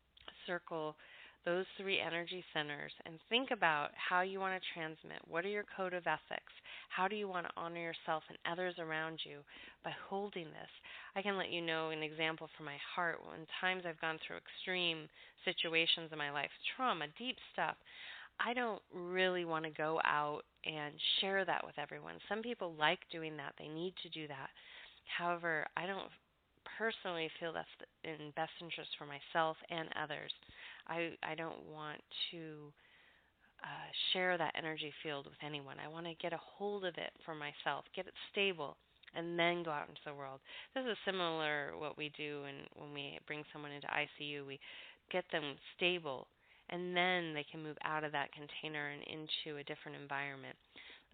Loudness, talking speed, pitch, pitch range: -41 LUFS, 180 wpm, 165 Hz, 150-180 Hz